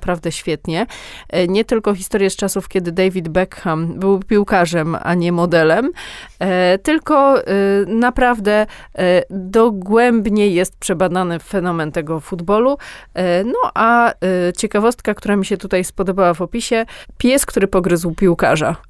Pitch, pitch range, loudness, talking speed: 195 Hz, 180-225 Hz, -16 LUFS, 115 wpm